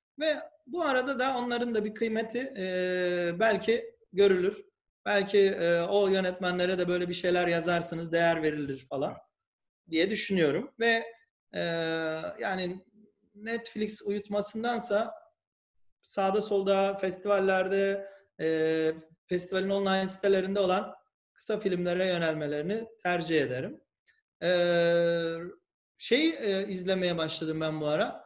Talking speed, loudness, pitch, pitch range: 110 wpm, -29 LUFS, 195 Hz, 175-225 Hz